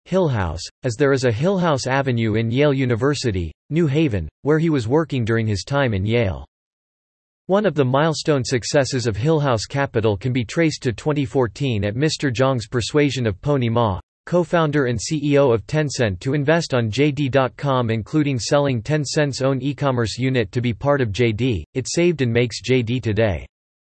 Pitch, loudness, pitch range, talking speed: 130 Hz, -20 LUFS, 115-145 Hz, 175 wpm